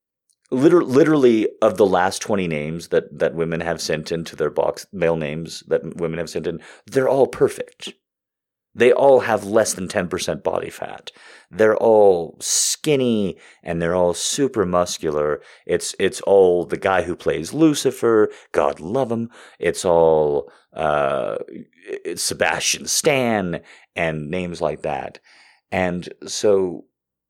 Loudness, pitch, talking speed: -19 LUFS, 95 Hz, 145 wpm